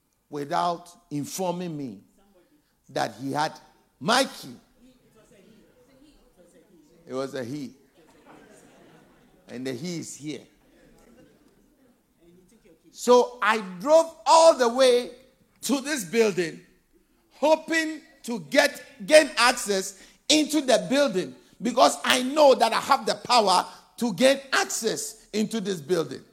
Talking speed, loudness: 110 wpm, -23 LUFS